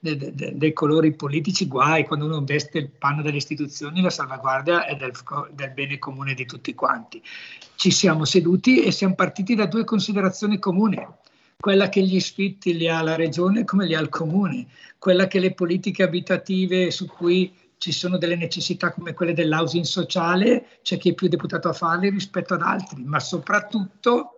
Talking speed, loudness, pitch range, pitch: 180 wpm, -22 LUFS, 160-190 Hz, 175 Hz